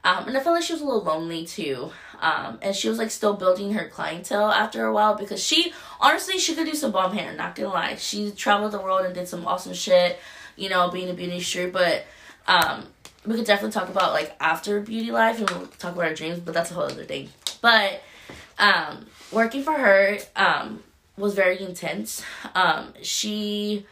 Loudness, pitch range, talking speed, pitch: -23 LUFS, 180-225 Hz, 215 wpm, 205 Hz